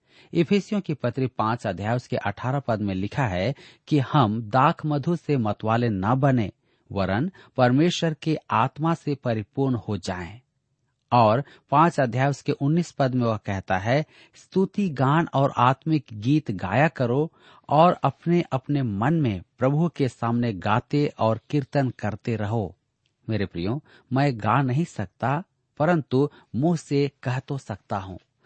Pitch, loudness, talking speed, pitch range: 130 Hz, -24 LUFS, 150 wpm, 115-145 Hz